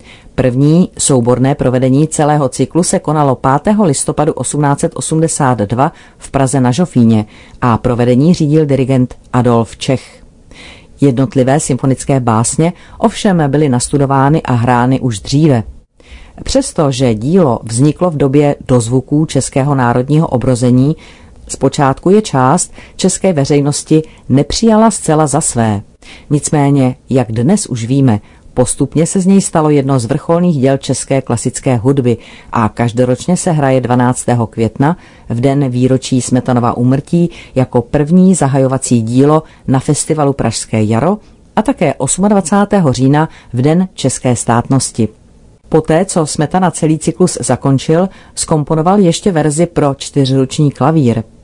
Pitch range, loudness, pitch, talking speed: 125-160 Hz, -12 LUFS, 140 Hz, 120 wpm